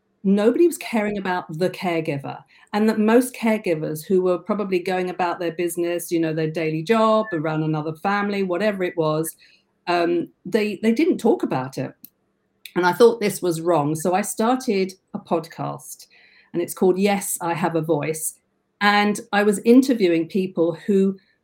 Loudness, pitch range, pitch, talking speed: -21 LUFS, 170-210 Hz, 185 Hz, 170 wpm